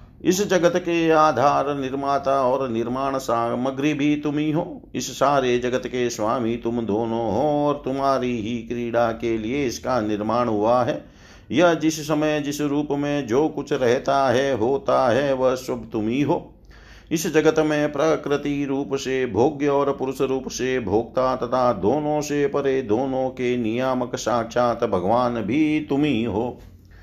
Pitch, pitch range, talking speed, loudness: 135 Hz, 120-145 Hz, 155 wpm, -22 LUFS